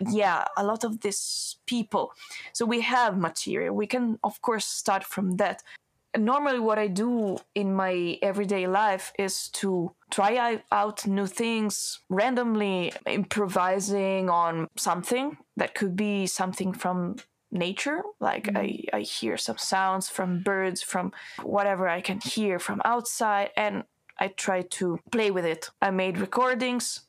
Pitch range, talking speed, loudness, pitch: 190-220 Hz, 150 wpm, -27 LUFS, 200 Hz